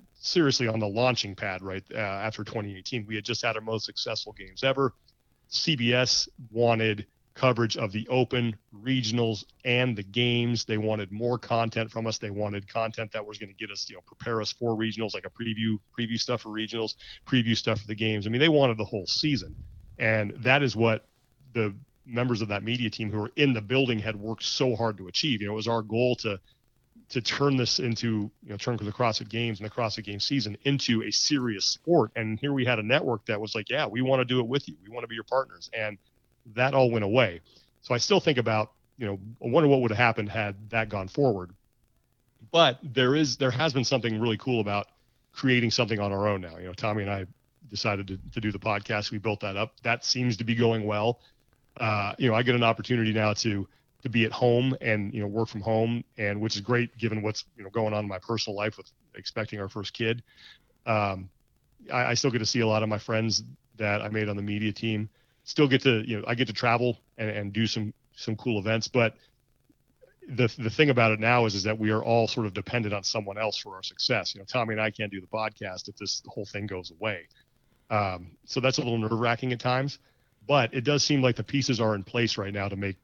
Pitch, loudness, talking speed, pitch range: 115 Hz, -27 LUFS, 240 wpm, 105-125 Hz